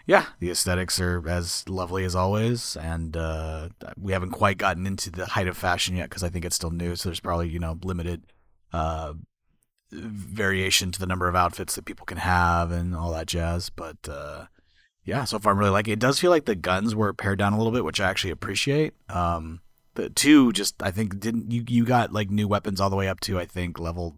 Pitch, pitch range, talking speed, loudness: 90 Hz, 85-105 Hz, 230 wpm, -25 LUFS